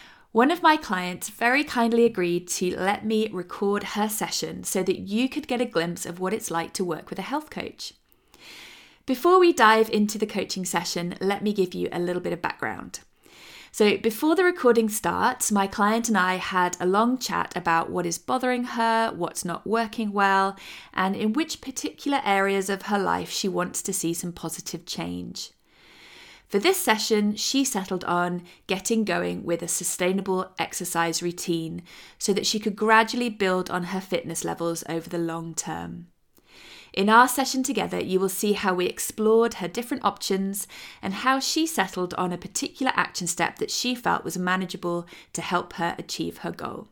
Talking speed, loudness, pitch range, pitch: 185 wpm, -25 LUFS, 180-225 Hz, 195 Hz